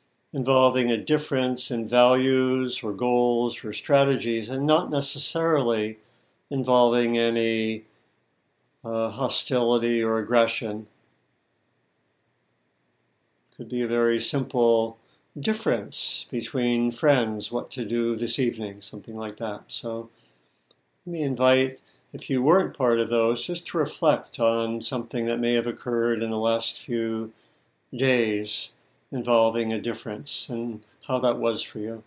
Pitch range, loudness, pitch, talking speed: 115-130 Hz, -25 LUFS, 120 Hz, 125 wpm